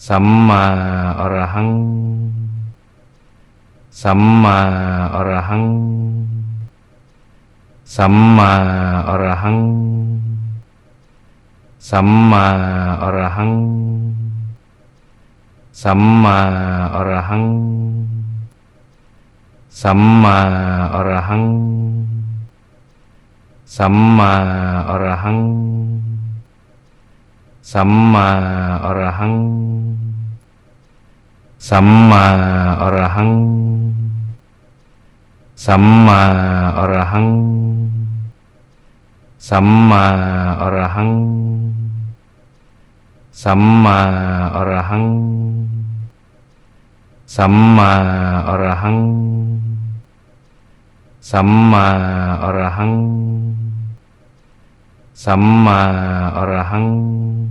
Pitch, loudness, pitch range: 110 Hz, -14 LUFS, 95-115 Hz